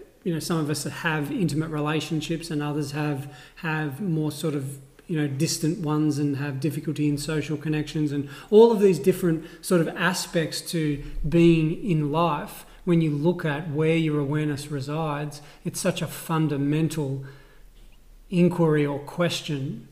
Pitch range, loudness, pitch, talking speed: 145-170 Hz, -25 LUFS, 155 Hz, 155 wpm